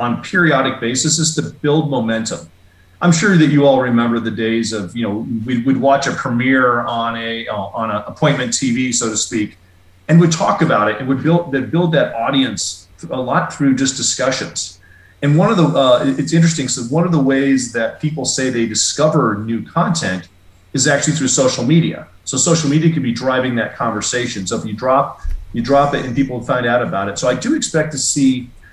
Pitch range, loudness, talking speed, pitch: 115-145 Hz, -16 LUFS, 210 wpm, 130 Hz